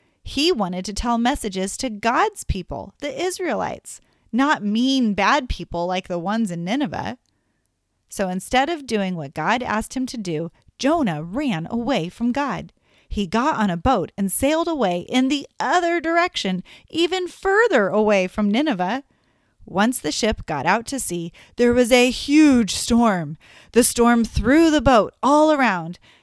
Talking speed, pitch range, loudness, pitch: 160 wpm, 195-285 Hz, -20 LUFS, 235 Hz